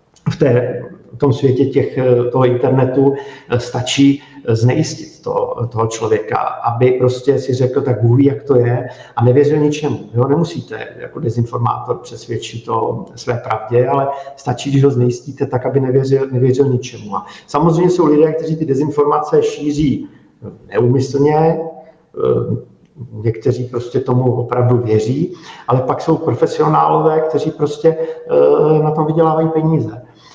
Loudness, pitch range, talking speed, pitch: -15 LUFS, 125-155 Hz, 130 wpm, 140 Hz